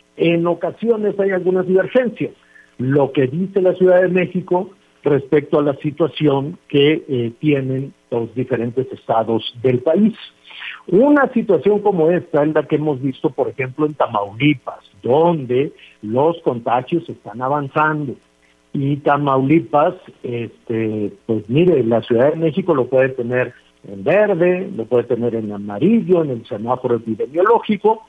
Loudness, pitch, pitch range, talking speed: -17 LUFS, 145 Hz, 120-180 Hz, 140 wpm